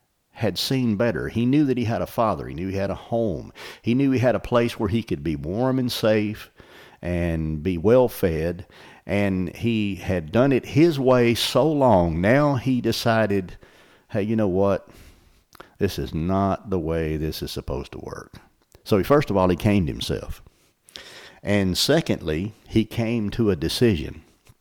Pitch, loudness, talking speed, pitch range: 100 Hz, -22 LUFS, 180 wpm, 90-115 Hz